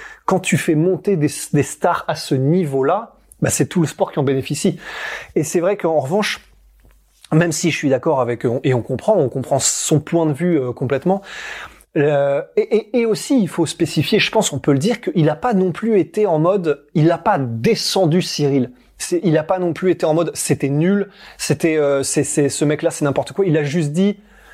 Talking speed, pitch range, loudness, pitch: 225 wpm, 145-190 Hz, -18 LUFS, 165 Hz